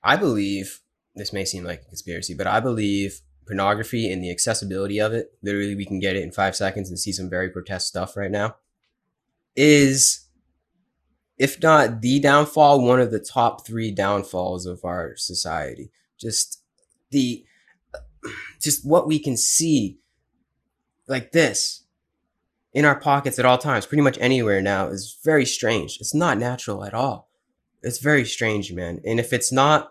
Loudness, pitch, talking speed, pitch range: -21 LUFS, 110 Hz, 165 wpm, 95-135 Hz